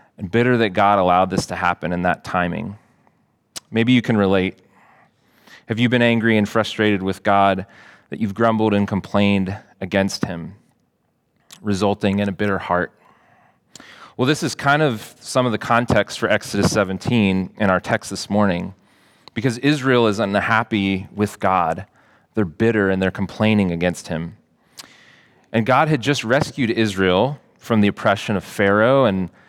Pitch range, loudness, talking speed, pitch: 95-115 Hz, -19 LUFS, 155 wpm, 105 Hz